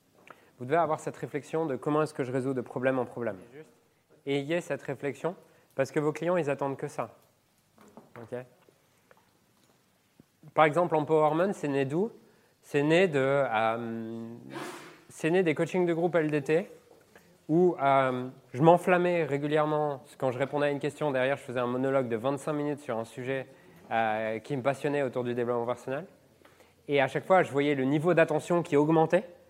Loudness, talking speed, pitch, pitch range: -28 LUFS, 175 wpm, 145 Hz, 130-160 Hz